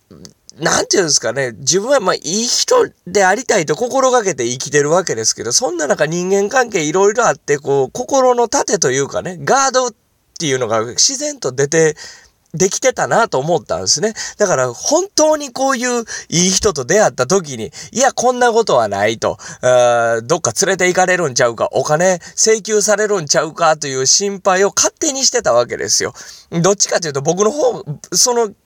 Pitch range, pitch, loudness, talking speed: 155-245 Hz, 195 Hz, -14 LUFS, 375 characters per minute